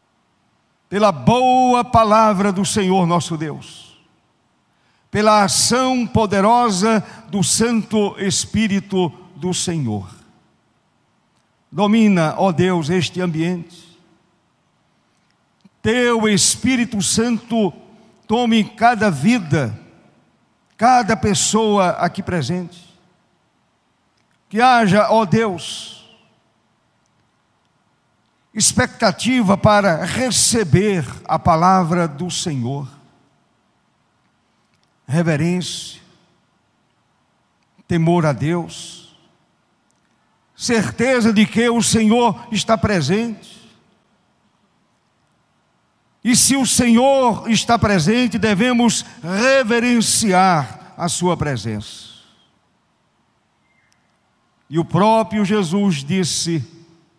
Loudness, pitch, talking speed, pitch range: -16 LUFS, 195 Hz, 70 wpm, 170-225 Hz